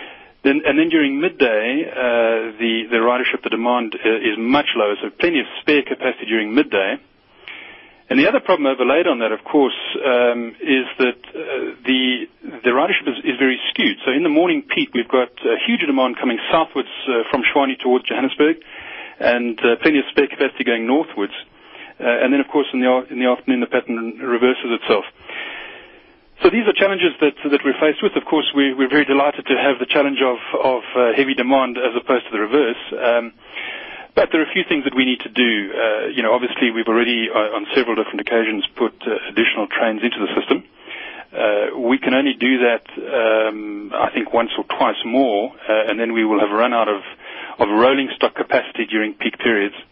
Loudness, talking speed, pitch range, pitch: -18 LUFS, 200 wpm, 115-160 Hz, 130 Hz